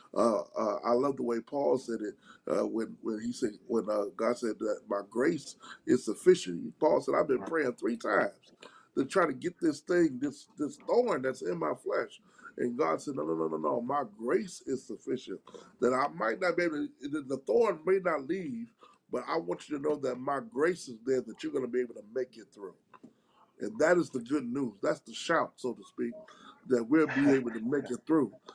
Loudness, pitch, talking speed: -32 LUFS, 135 Hz, 225 wpm